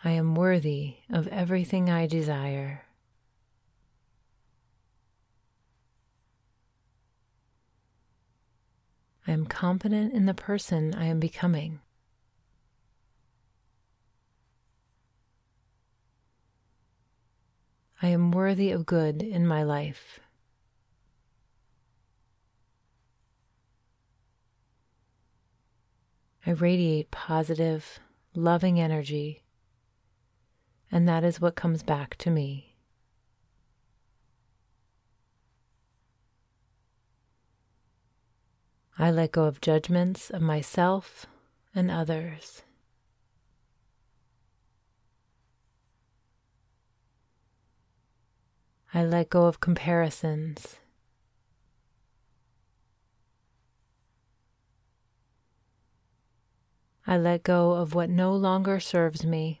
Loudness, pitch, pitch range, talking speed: -27 LUFS, 115 Hz, 115-160 Hz, 60 wpm